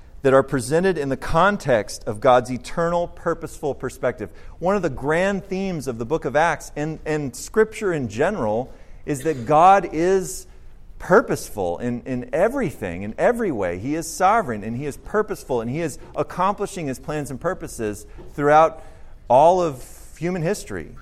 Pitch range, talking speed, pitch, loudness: 130-180 Hz, 165 wpm, 155 Hz, -21 LUFS